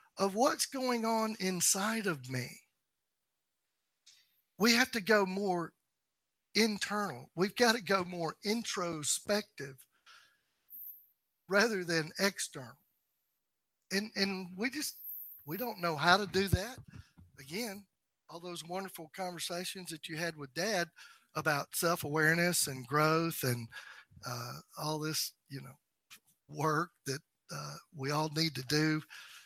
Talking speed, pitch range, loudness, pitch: 125 wpm, 155-205 Hz, -33 LUFS, 175 Hz